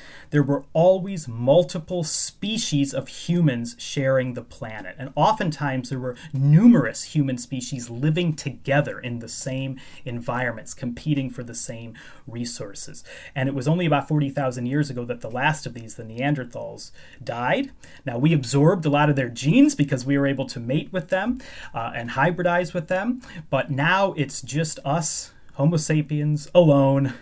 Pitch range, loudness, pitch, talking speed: 130-160 Hz, -23 LUFS, 140 Hz, 160 wpm